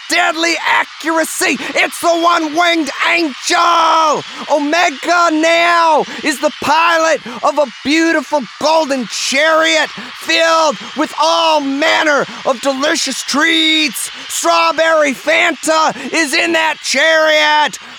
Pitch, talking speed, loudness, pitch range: 315 Hz, 100 wpm, -12 LUFS, 290-330 Hz